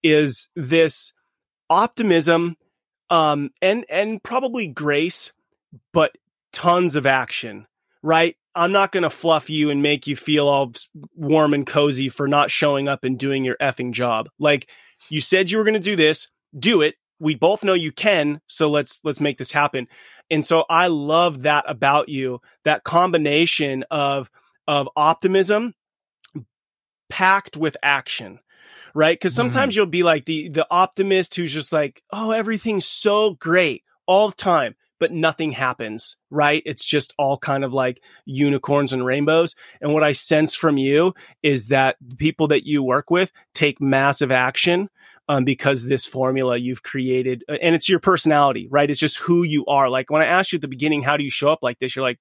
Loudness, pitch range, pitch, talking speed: -19 LUFS, 140-170 Hz, 150 Hz, 180 wpm